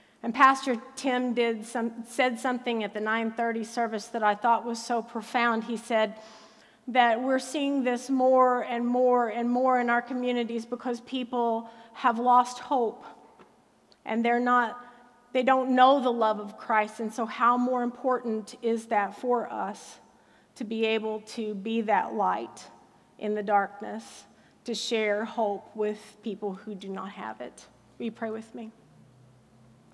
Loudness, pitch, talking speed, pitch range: -27 LUFS, 235 Hz, 160 wpm, 220-245 Hz